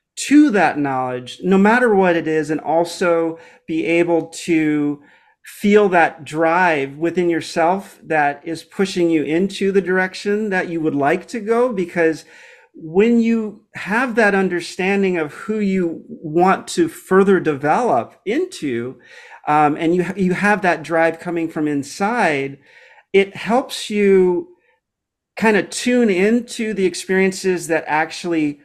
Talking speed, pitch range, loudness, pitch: 140 wpm, 160-205 Hz, -18 LUFS, 180 Hz